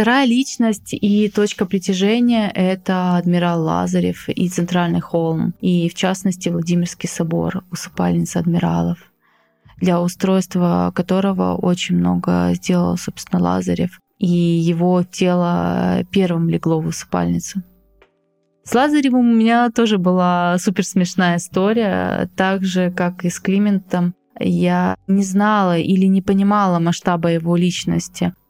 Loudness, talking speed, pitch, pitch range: -18 LUFS, 120 wpm, 180 Hz, 165-195 Hz